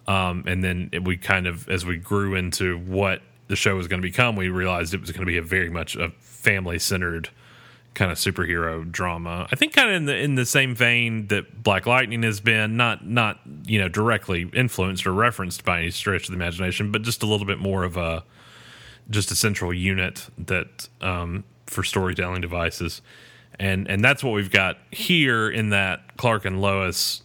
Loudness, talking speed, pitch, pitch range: -22 LUFS, 205 wpm, 95 Hz, 90-110 Hz